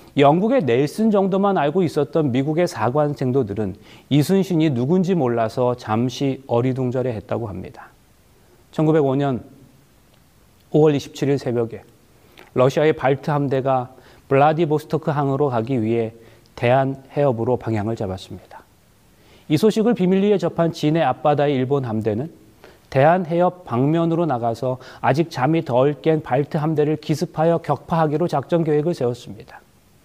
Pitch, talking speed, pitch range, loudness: 140 Hz, 300 characters per minute, 125-160 Hz, -20 LUFS